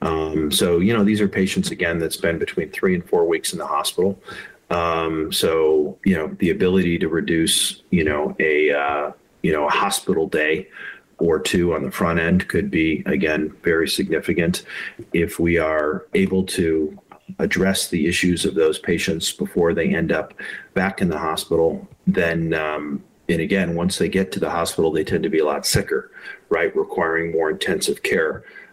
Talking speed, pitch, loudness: 180 wpm, 90 Hz, -20 LUFS